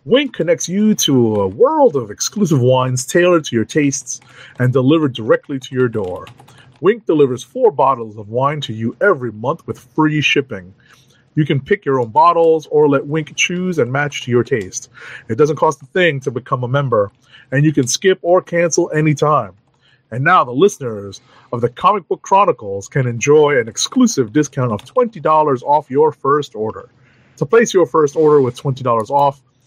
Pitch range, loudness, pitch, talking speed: 125-165 Hz, -15 LUFS, 140 Hz, 185 wpm